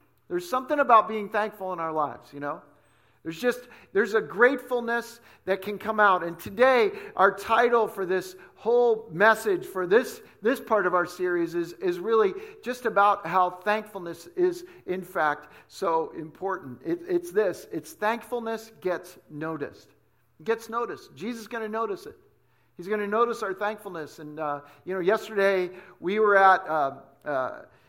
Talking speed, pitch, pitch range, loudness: 170 wpm, 210 Hz, 180-240 Hz, -26 LUFS